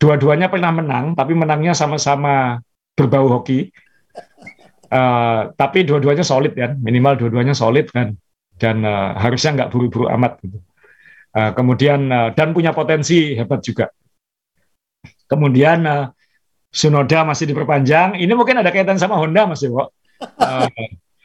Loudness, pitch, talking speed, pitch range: -16 LUFS, 140 Hz, 130 wpm, 120-155 Hz